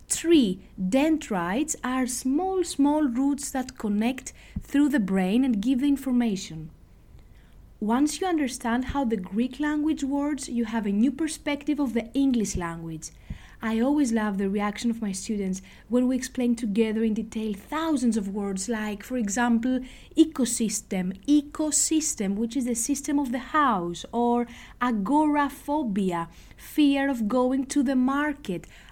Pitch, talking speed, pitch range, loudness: 250 Hz, 145 wpm, 215-285 Hz, -26 LUFS